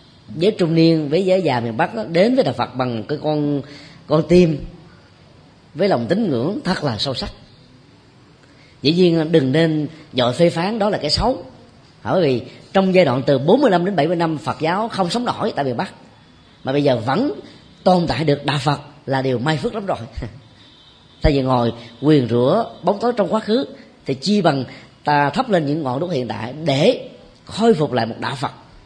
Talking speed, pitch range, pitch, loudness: 210 wpm, 135-180 Hz, 150 Hz, -18 LUFS